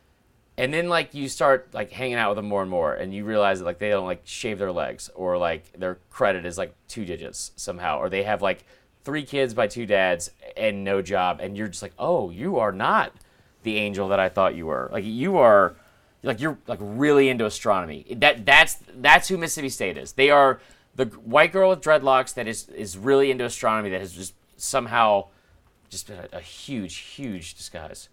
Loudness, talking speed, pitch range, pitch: -22 LUFS, 215 wpm, 95-135 Hz, 110 Hz